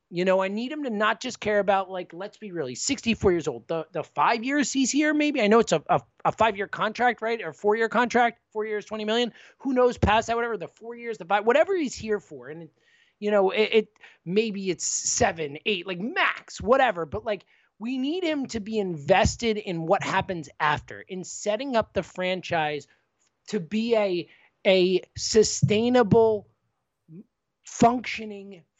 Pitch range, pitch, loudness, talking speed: 185-230 Hz, 210 Hz, -25 LUFS, 190 wpm